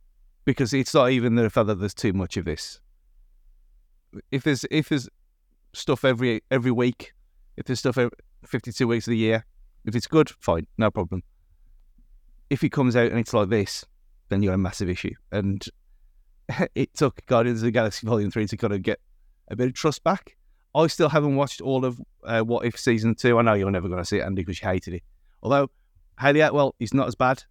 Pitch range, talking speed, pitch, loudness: 95-130 Hz, 210 wpm, 115 Hz, -24 LUFS